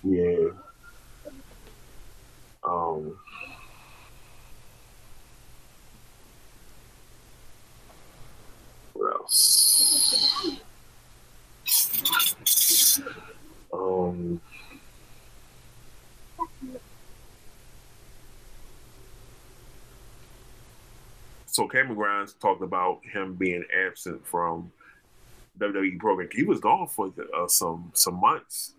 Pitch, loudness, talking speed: 125 Hz, -23 LUFS, 50 wpm